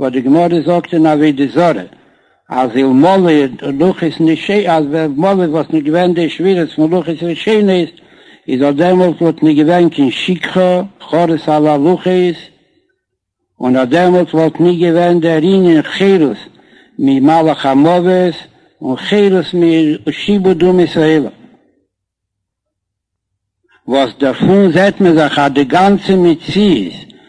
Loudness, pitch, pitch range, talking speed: -11 LUFS, 165 Hz, 150-180 Hz, 135 wpm